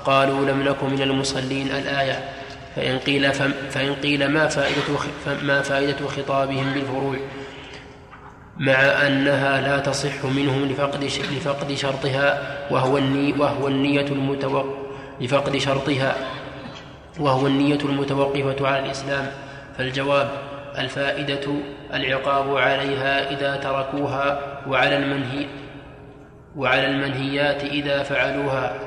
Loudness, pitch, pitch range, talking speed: -22 LUFS, 140 Hz, 135-140 Hz, 85 wpm